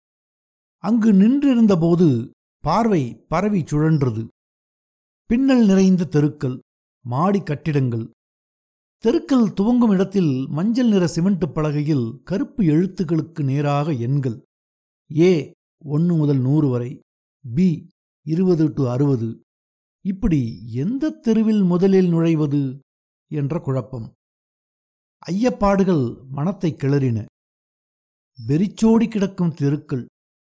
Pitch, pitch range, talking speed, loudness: 155 Hz, 135-195 Hz, 85 wpm, -19 LUFS